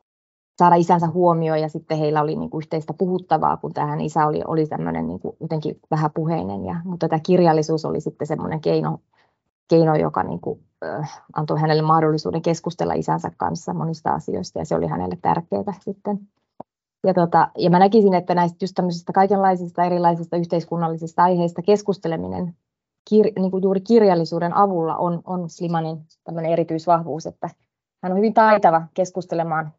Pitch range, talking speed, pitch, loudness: 155-180 Hz, 155 wpm, 170 Hz, -20 LUFS